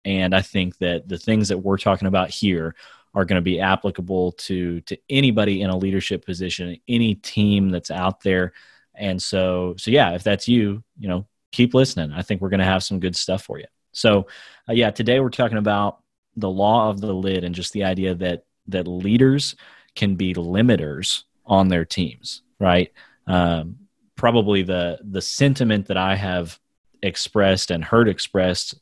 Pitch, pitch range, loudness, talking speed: 95 Hz, 90-105 Hz, -21 LUFS, 185 wpm